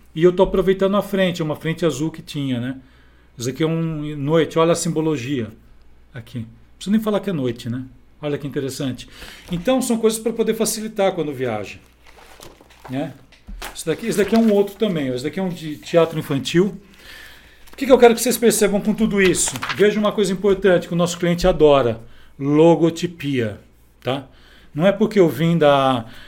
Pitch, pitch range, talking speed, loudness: 165 Hz, 135-200 Hz, 190 wpm, -19 LUFS